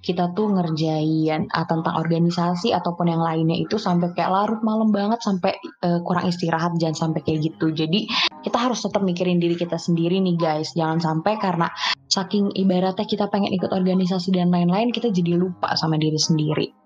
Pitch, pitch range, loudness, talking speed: 175 Hz, 165-200 Hz, -21 LUFS, 180 wpm